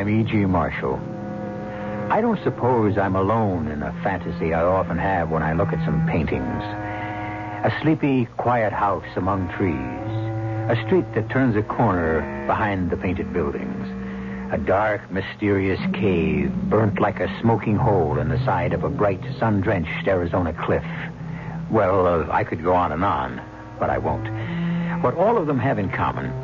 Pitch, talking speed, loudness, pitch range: 105 Hz, 165 wpm, -22 LUFS, 90-115 Hz